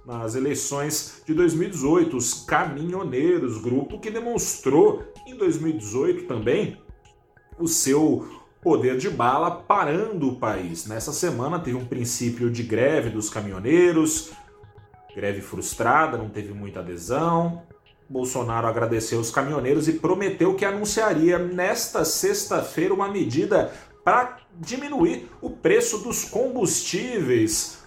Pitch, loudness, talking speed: 150 Hz, -23 LUFS, 115 wpm